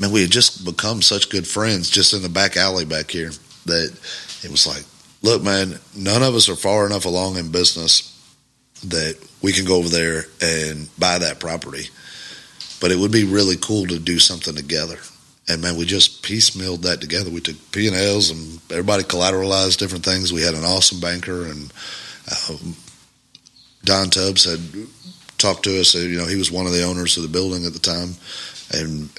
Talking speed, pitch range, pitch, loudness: 190 wpm, 85-100 Hz, 90 Hz, -17 LUFS